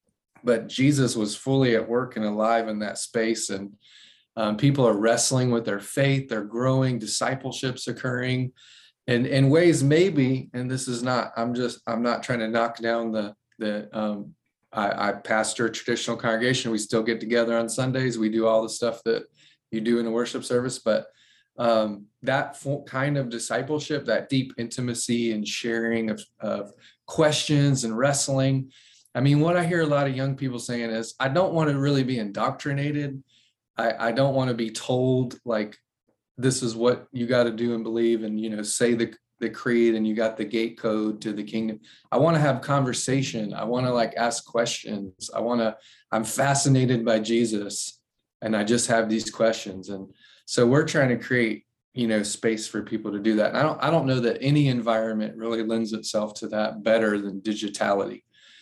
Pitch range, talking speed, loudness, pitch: 110-130 Hz, 195 wpm, -25 LUFS, 115 Hz